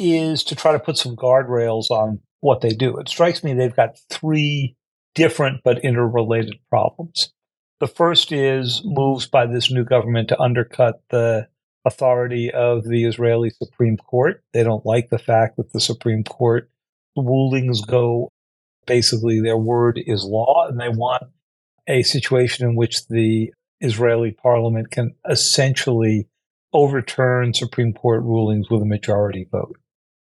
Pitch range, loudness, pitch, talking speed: 115-135 Hz, -19 LUFS, 120 Hz, 145 wpm